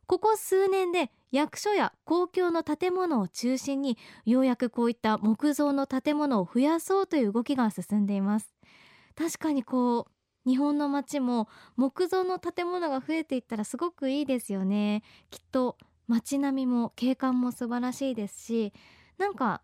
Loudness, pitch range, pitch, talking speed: -28 LUFS, 235-320 Hz, 265 Hz, 310 characters per minute